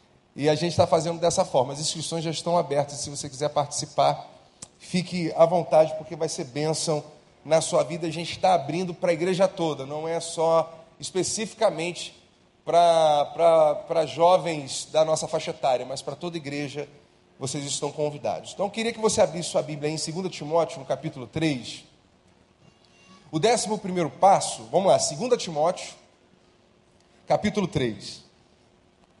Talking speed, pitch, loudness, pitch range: 155 wpm, 160 Hz, -25 LUFS, 150-175 Hz